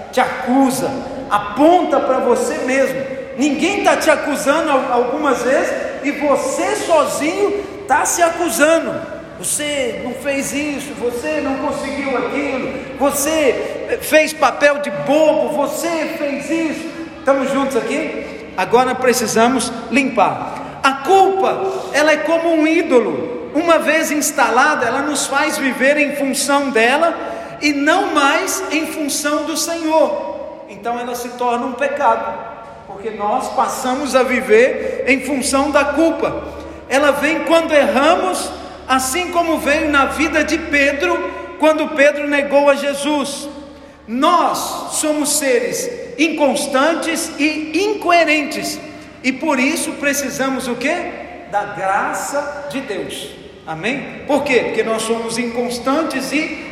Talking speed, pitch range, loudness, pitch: 125 wpm, 265-310 Hz, -16 LUFS, 285 Hz